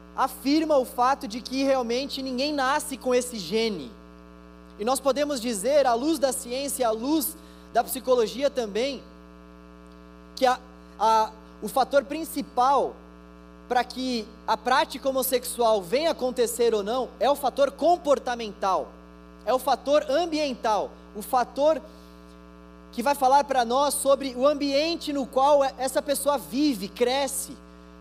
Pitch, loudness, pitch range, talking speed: 250 Hz, -25 LUFS, 200-275 Hz, 135 wpm